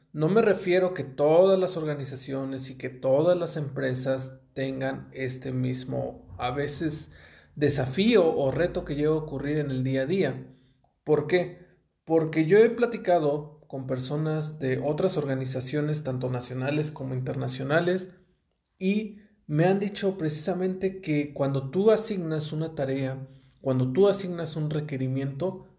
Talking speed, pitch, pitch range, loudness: 140 wpm, 150 Hz, 135-180 Hz, -27 LUFS